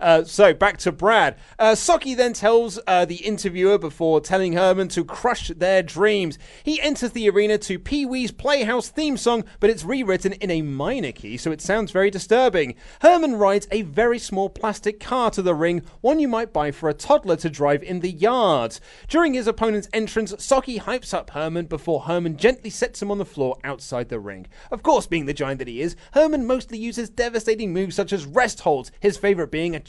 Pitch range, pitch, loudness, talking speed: 170-230 Hz, 200 Hz, -21 LUFS, 205 wpm